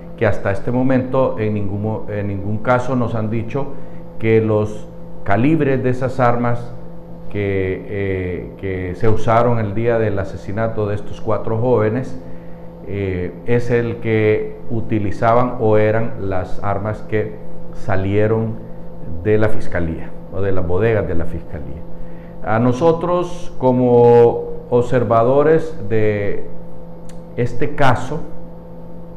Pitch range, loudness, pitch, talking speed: 100-125 Hz, -18 LUFS, 110 Hz, 120 wpm